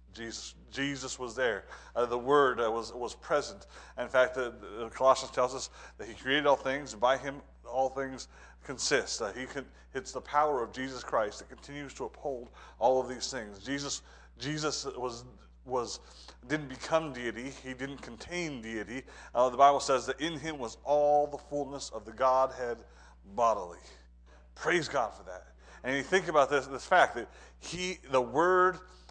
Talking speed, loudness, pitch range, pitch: 185 wpm, -31 LUFS, 120-145 Hz, 130 Hz